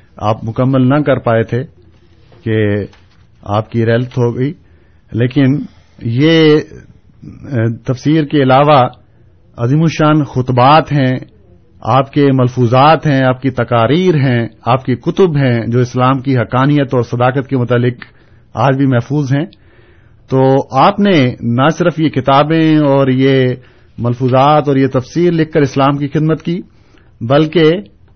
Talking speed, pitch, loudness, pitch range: 135 wpm, 130 Hz, -12 LUFS, 115-145 Hz